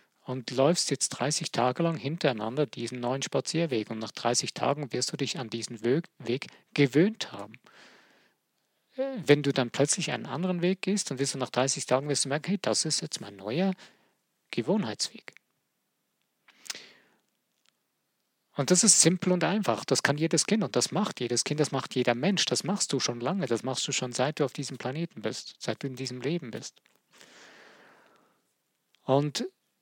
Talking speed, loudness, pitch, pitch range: 175 wpm, -28 LUFS, 140 Hz, 125-170 Hz